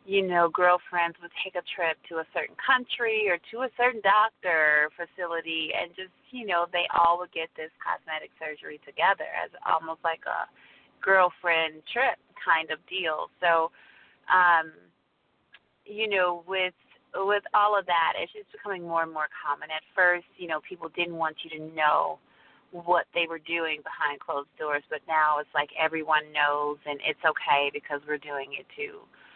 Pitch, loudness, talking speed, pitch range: 165 Hz, -27 LUFS, 175 wpm, 155-185 Hz